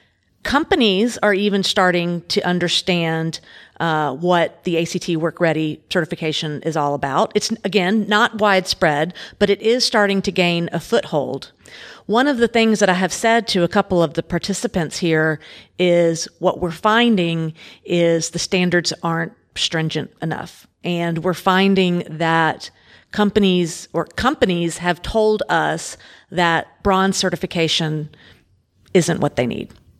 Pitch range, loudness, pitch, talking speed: 165-200 Hz, -18 LUFS, 175 Hz, 140 wpm